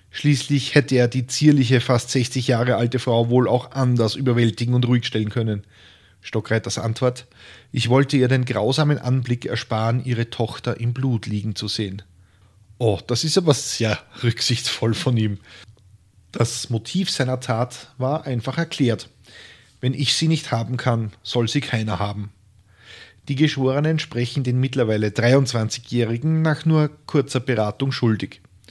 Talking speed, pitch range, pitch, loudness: 145 wpm, 110-130 Hz, 120 Hz, -21 LUFS